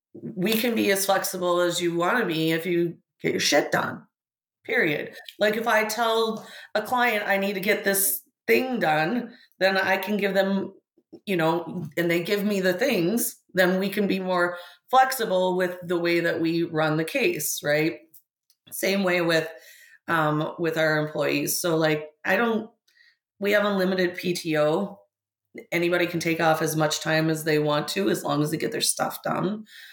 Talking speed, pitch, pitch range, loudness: 185 wpm, 180 Hz, 160-200 Hz, -24 LUFS